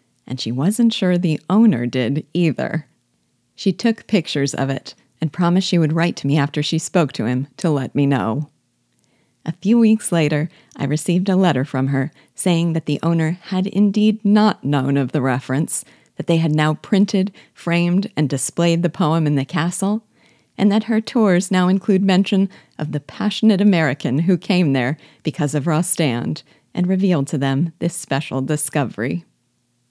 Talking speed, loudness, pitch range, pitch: 175 wpm, -19 LUFS, 140-190 Hz, 165 Hz